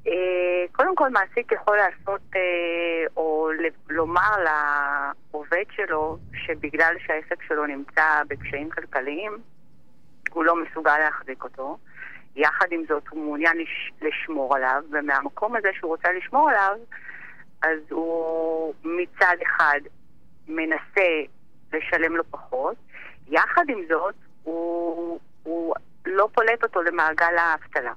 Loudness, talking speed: -23 LUFS, 110 wpm